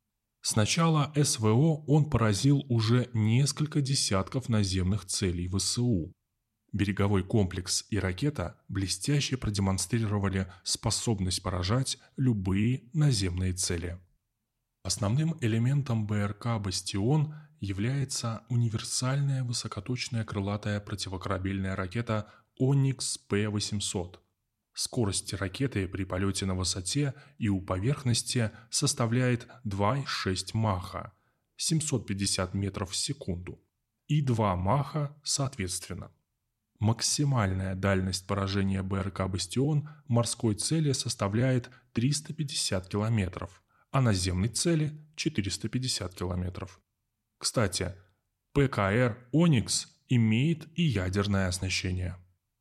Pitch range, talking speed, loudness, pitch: 95-130 Hz, 85 wpm, -29 LUFS, 110 Hz